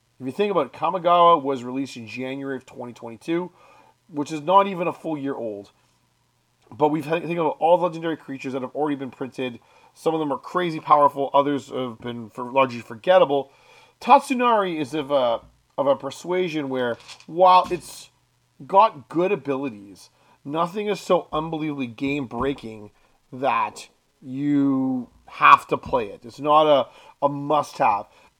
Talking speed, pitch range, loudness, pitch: 165 wpm, 130-170 Hz, -22 LUFS, 145 Hz